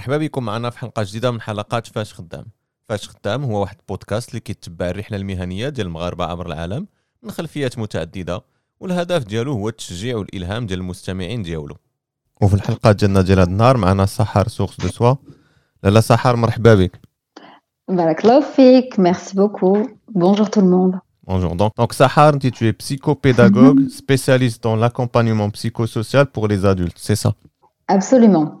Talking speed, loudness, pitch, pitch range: 155 wpm, -17 LUFS, 115 Hz, 100-140 Hz